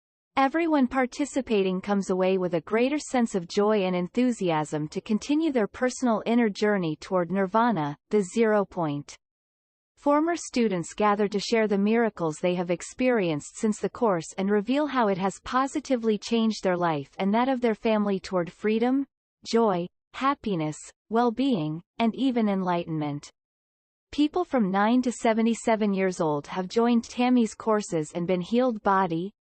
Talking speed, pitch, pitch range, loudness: 150 wpm, 210 Hz, 180-240 Hz, -26 LUFS